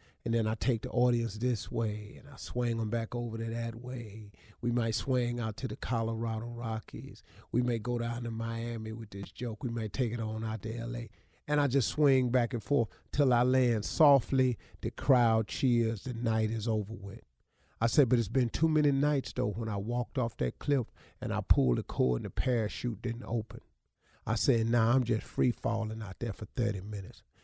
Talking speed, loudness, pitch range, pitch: 215 wpm, -31 LUFS, 110-125 Hz, 115 Hz